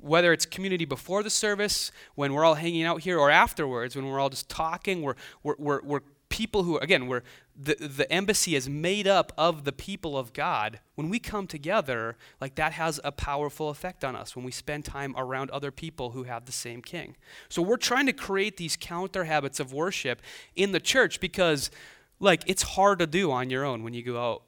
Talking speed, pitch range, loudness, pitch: 220 wpm, 135-185 Hz, -27 LUFS, 155 Hz